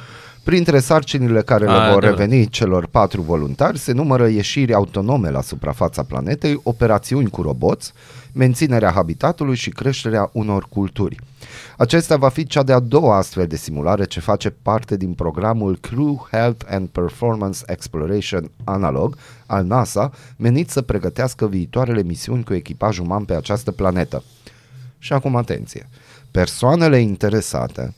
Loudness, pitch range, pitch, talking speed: -18 LUFS, 95-130 Hz, 110 Hz, 135 wpm